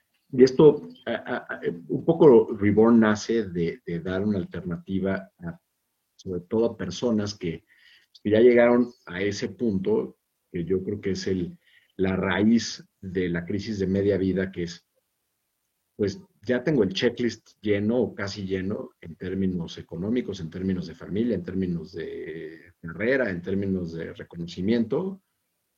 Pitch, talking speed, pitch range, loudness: 100 Hz, 150 wpm, 90-120 Hz, -25 LUFS